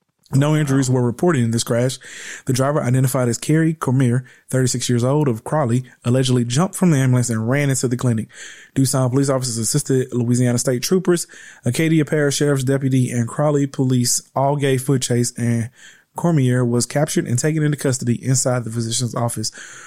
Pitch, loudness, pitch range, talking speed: 130 Hz, -19 LUFS, 120-145 Hz, 175 wpm